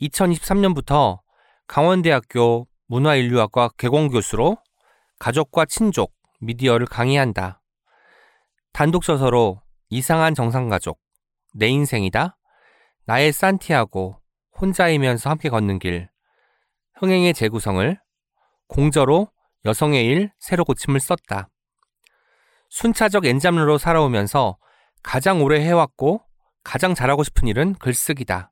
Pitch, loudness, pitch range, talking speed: 140 Hz, -19 LUFS, 115-170 Hz, 250 characters per minute